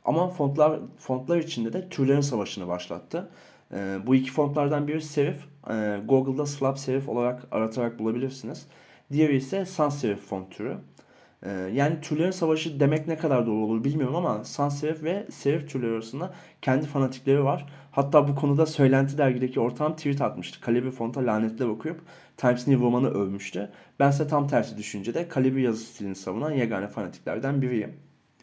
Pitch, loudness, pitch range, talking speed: 135 Hz, -26 LUFS, 120-150 Hz, 160 wpm